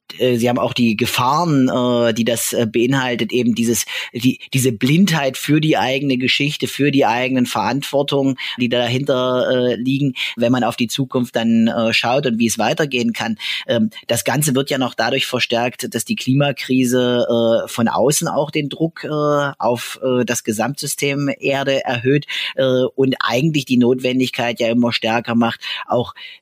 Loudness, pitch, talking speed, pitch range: -17 LUFS, 125 Hz, 150 wpm, 120-135 Hz